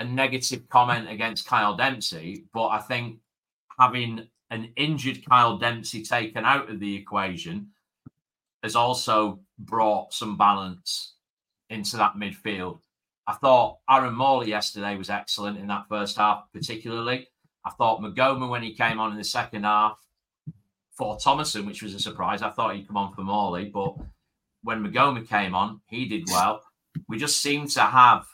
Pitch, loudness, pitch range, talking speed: 110 Hz, -24 LUFS, 105-125 Hz, 160 wpm